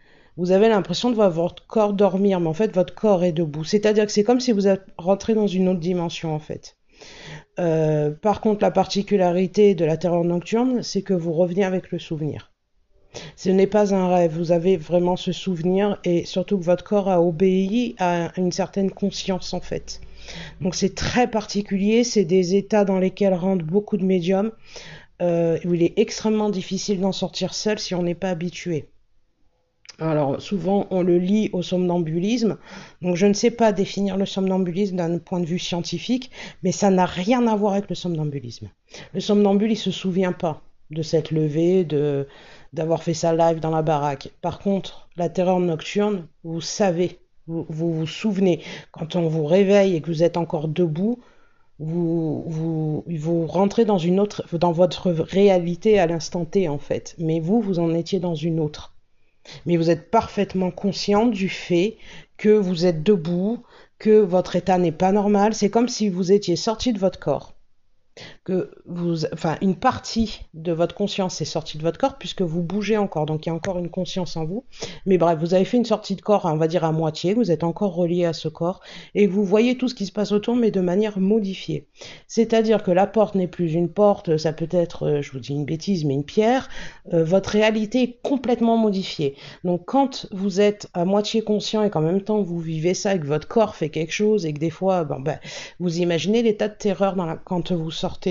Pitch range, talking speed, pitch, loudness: 170-205 Hz, 205 wpm, 185 Hz, -22 LUFS